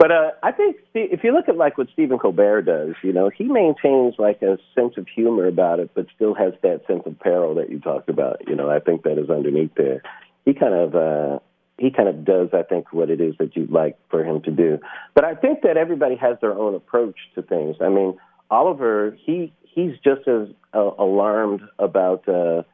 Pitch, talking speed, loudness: 105 Hz, 225 wpm, -20 LUFS